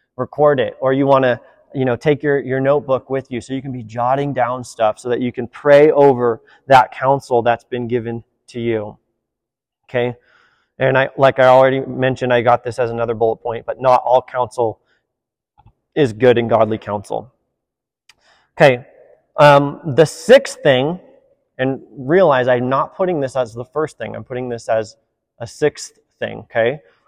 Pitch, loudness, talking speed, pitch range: 130 Hz, -16 LUFS, 175 wpm, 120-140 Hz